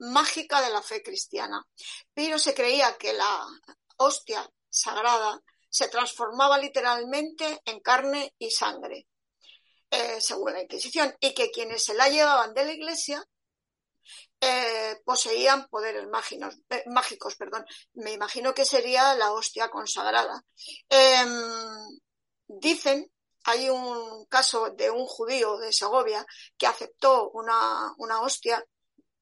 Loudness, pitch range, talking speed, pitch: -25 LUFS, 230-300 Hz, 125 wpm, 265 Hz